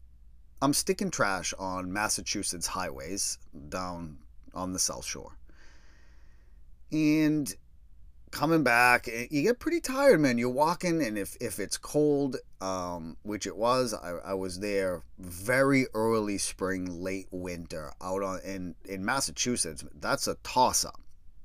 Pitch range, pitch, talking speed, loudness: 80-125 Hz, 95 Hz, 130 wpm, -29 LUFS